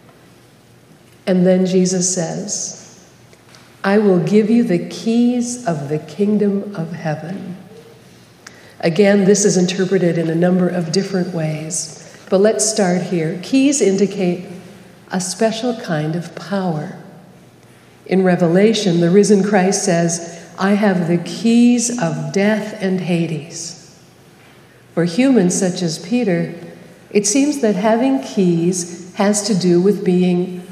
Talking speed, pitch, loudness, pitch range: 125 wpm, 185 Hz, -16 LUFS, 175-205 Hz